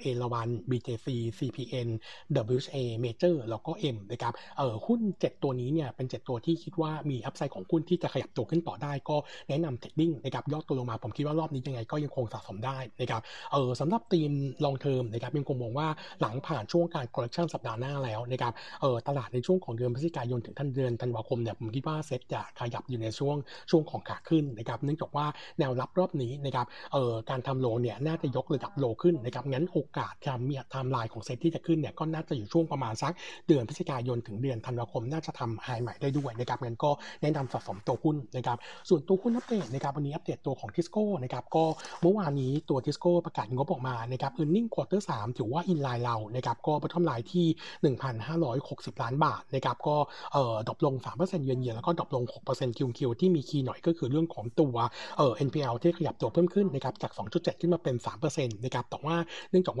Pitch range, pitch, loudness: 125-160 Hz, 140 Hz, -32 LUFS